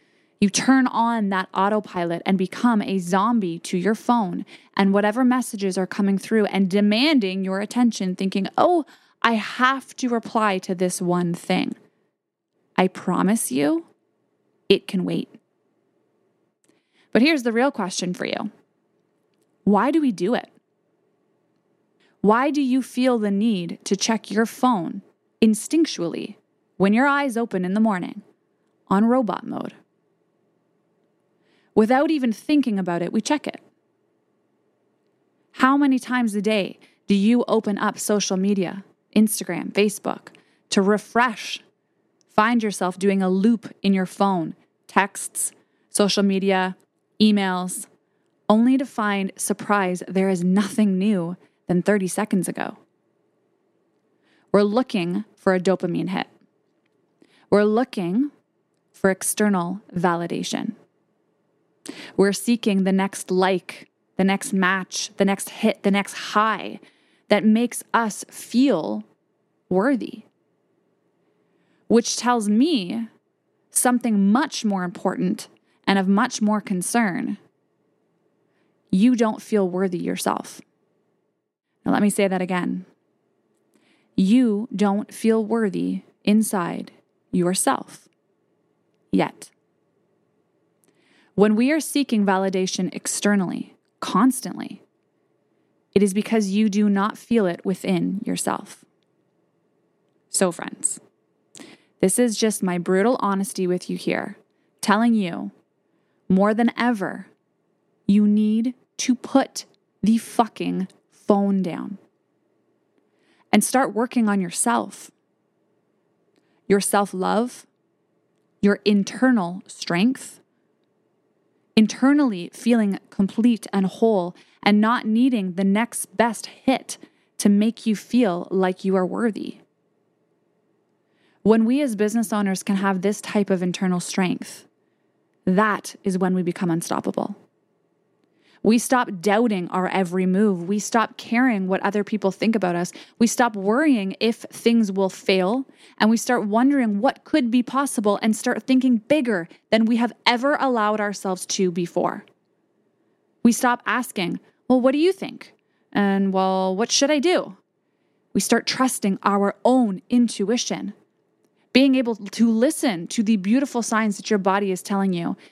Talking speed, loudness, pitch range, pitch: 125 wpm, -21 LUFS, 195-240 Hz, 210 Hz